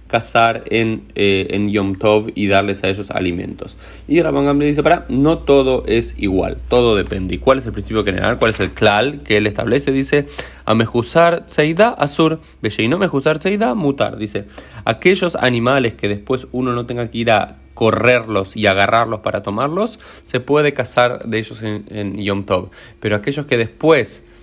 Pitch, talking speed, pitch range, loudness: 115 Hz, 185 wpm, 105-140 Hz, -16 LUFS